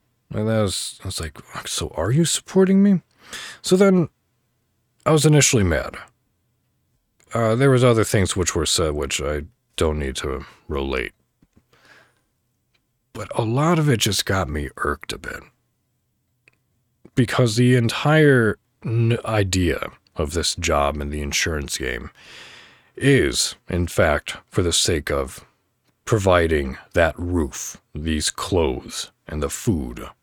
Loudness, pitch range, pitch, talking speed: -20 LUFS, 90-125 Hz, 115 Hz, 135 wpm